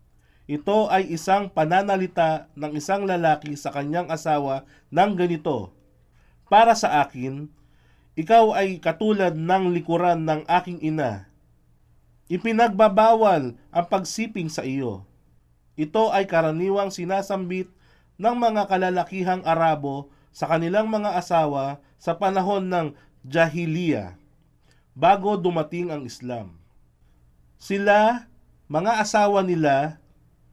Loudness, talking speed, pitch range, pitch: -22 LUFS, 100 wpm, 140-190 Hz, 165 Hz